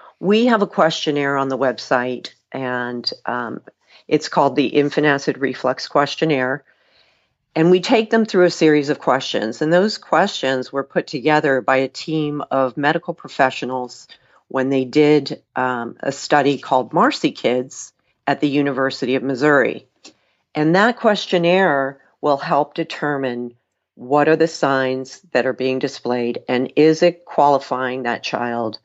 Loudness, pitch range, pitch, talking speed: -18 LUFS, 130-155 Hz, 140 Hz, 150 wpm